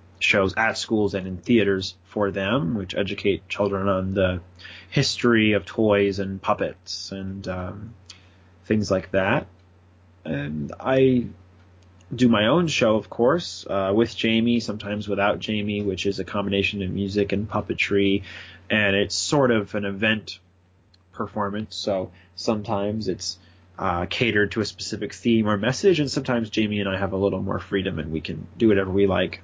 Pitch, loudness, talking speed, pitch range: 100 Hz, -23 LUFS, 165 wpm, 90-105 Hz